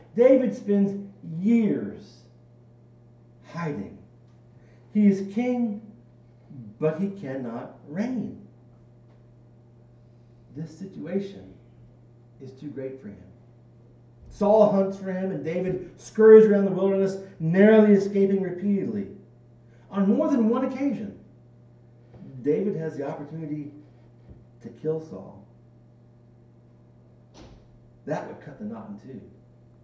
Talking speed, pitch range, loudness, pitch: 100 wpm, 120-195 Hz, -23 LUFS, 135 Hz